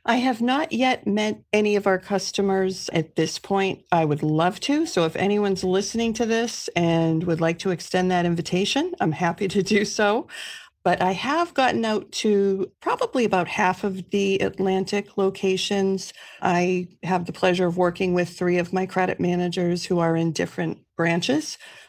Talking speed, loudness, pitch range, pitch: 175 wpm, -23 LUFS, 180-215 Hz, 190 Hz